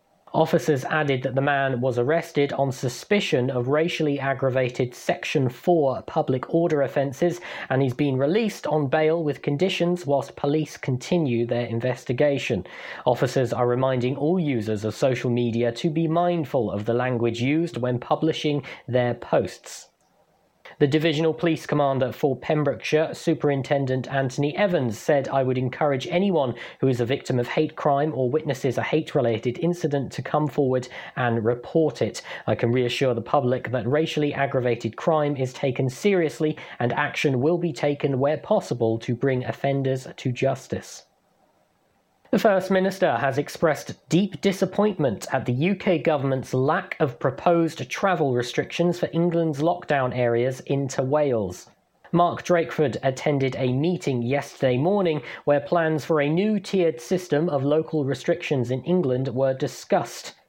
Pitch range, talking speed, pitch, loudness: 130-160 Hz, 150 wpm, 145 Hz, -24 LUFS